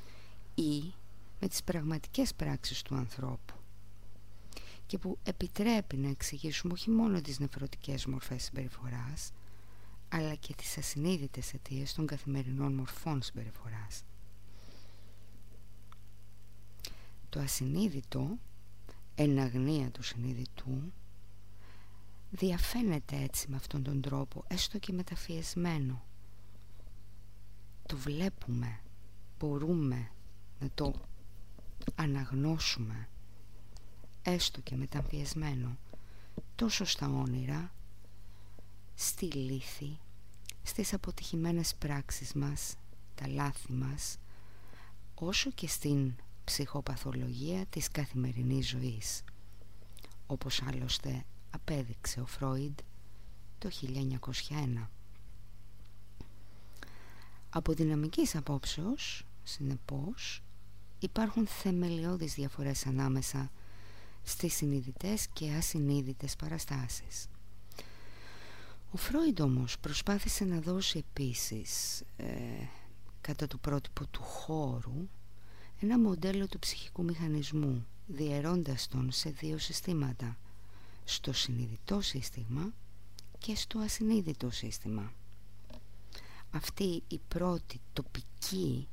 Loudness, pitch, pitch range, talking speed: -36 LUFS, 125 Hz, 100-150 Hz, 85 wpm